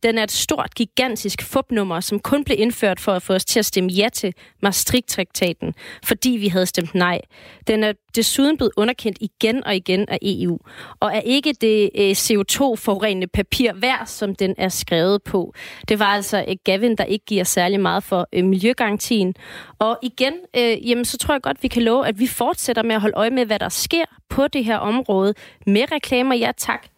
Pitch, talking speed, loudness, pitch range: 215 Hz, 205 wpm, -19 LUFS, 195-240 Hz